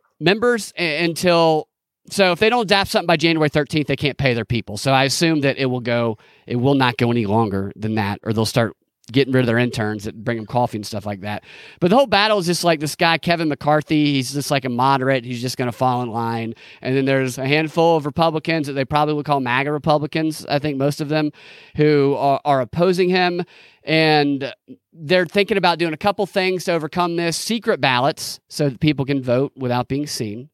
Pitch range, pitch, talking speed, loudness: 125-165 Hz, 145 Hz, 225 wpm, -19 LUFS